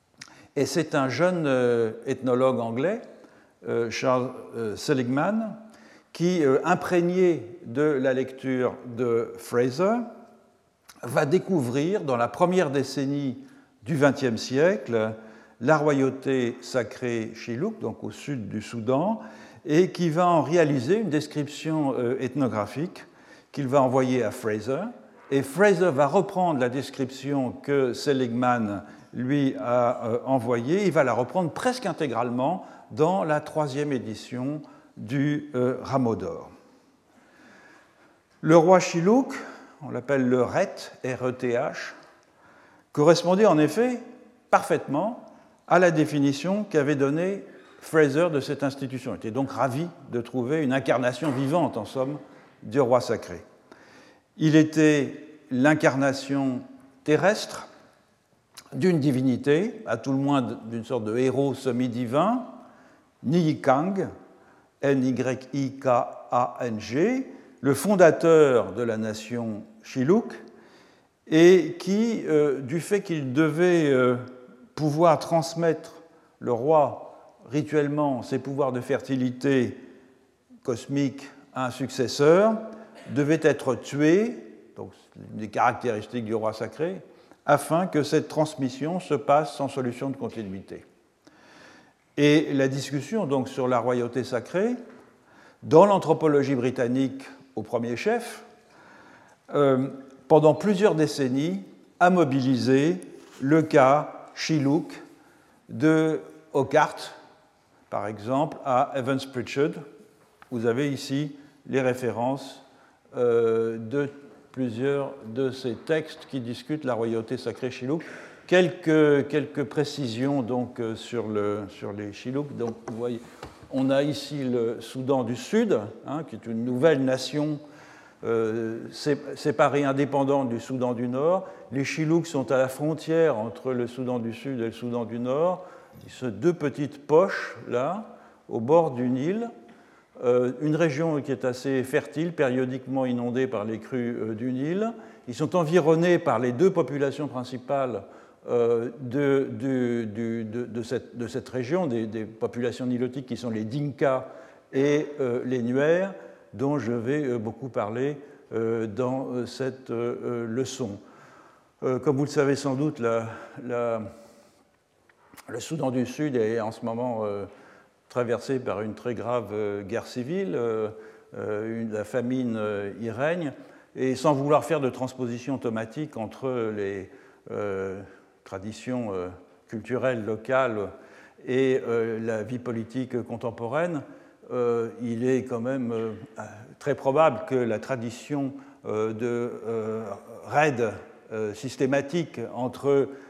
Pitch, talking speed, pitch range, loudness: 135 Hz, 125 wpm, 120-150 Hz, -25 LUFS